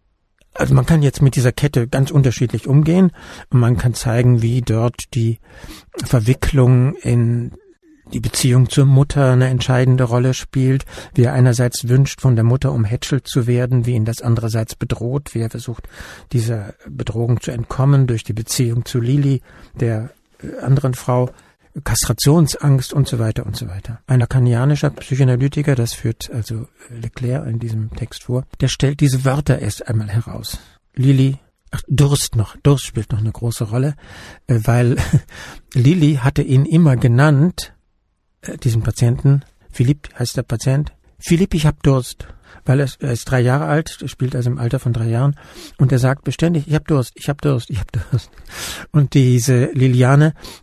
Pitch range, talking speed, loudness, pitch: 120-140 Hz, 160 wpm, -17 LUFS, 125 Hz